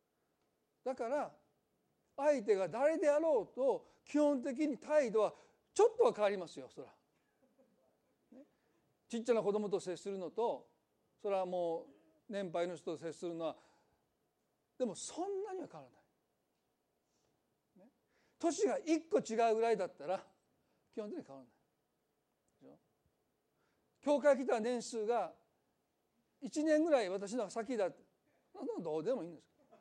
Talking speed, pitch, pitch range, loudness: 240 characters per minute, 235 Hz, 195-295 Hz, -37 LUFS